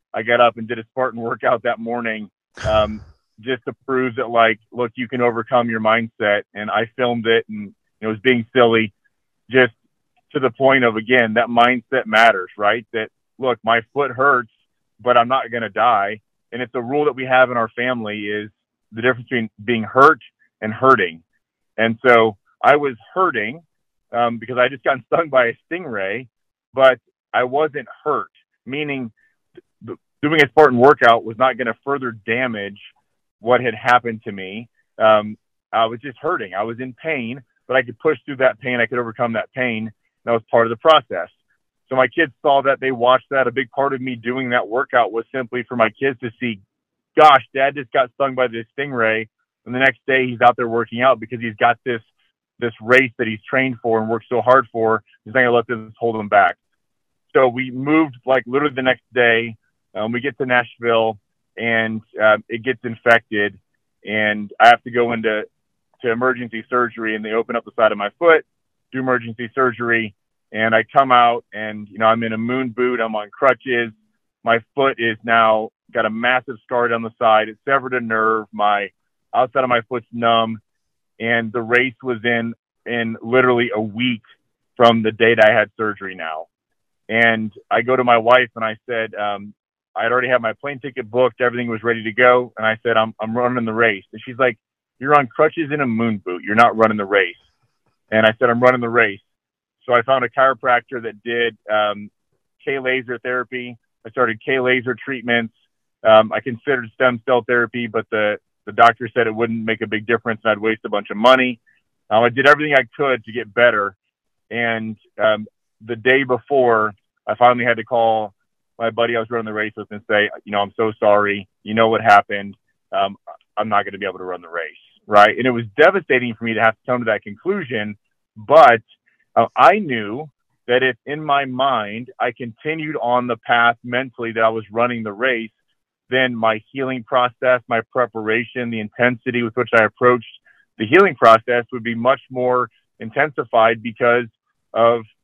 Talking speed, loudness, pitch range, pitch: 200 wpm, -18 LUFS, 110-125 Hz, 120 Hz